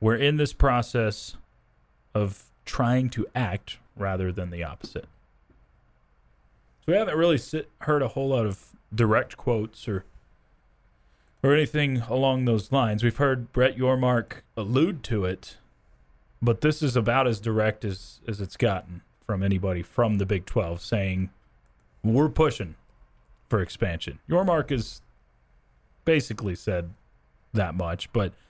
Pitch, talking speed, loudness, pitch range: 110 Hz, 135 wpm, -26 LUFS, 90-130 Hz